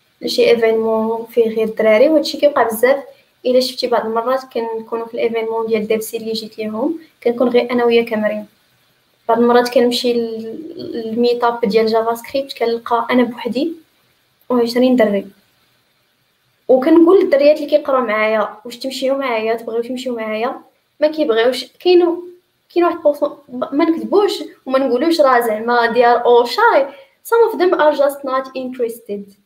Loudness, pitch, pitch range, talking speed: -16 LUFS, 245 Hz, 230-285 Hz, 145 wpm